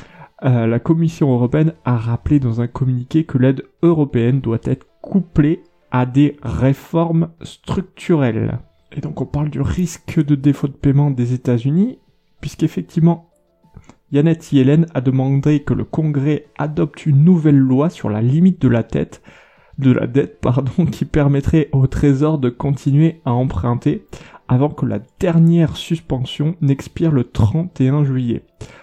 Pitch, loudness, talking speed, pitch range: 145 Hz, -17 LUFS, 145 wpm, 130-160 Hz